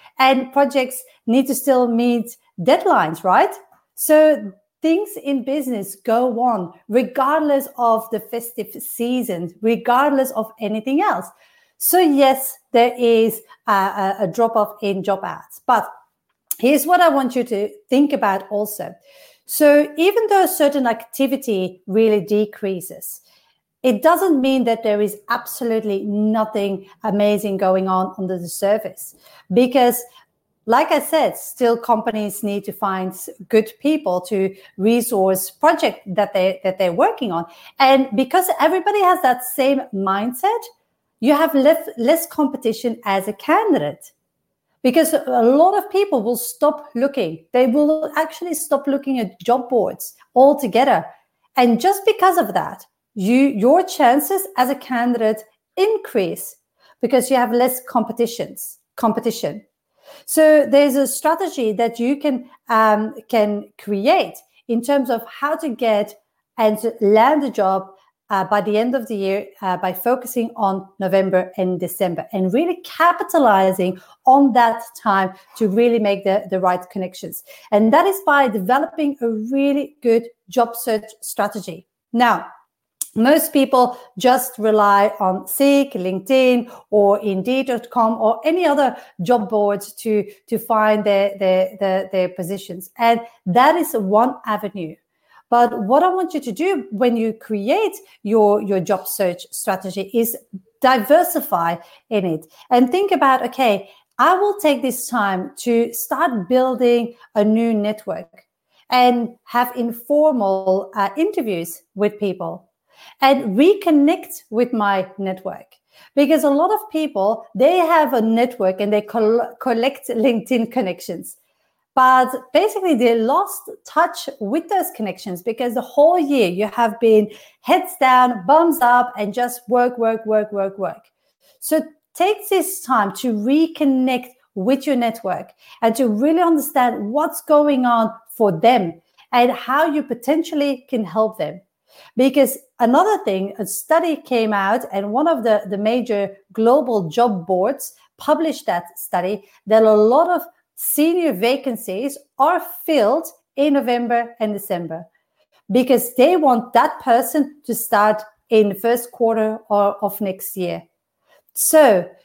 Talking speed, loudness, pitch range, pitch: 140 wpm, -18 LUFS, 210-280 Hz, 240 Hz